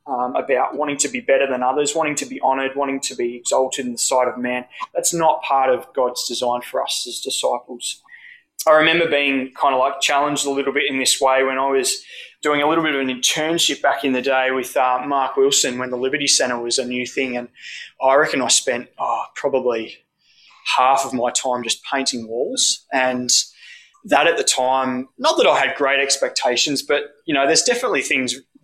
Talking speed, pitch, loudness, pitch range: 210 wpm, 135 Hz, -18 LUFS, 130-155 Hz